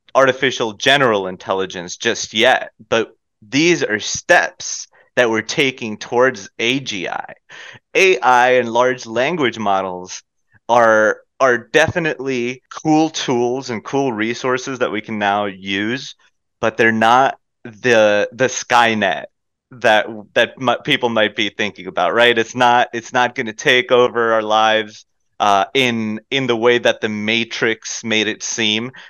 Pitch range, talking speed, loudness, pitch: 110-125 Hz, 140 wpm, -16 LUFS, 115 Hz